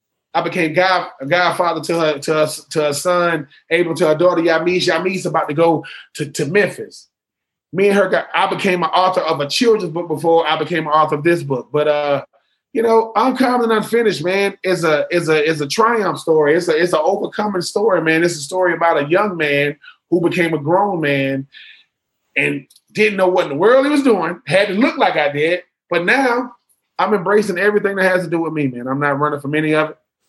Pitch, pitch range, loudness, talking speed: 175 Hz, 155-195 Hz, -16 LUFS, 225 wpm